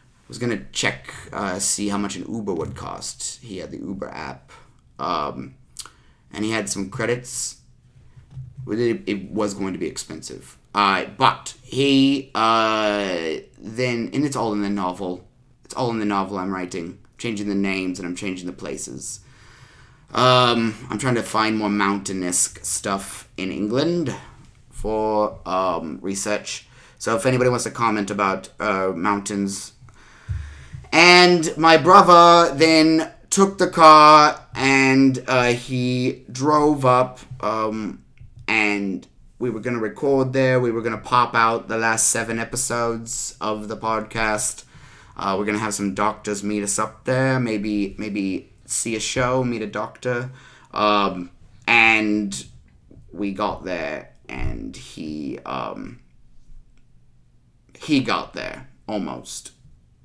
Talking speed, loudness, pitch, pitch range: 140 wpm, -20 LUFS, 110 Hz, 100-125 Hz